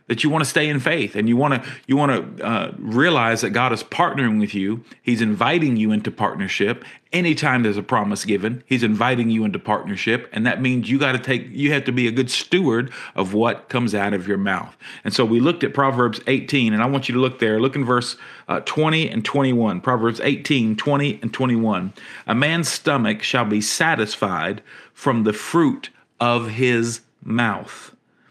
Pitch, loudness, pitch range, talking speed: 120 Hz, -20 LUFS, 110-135 Hz, 195 wpm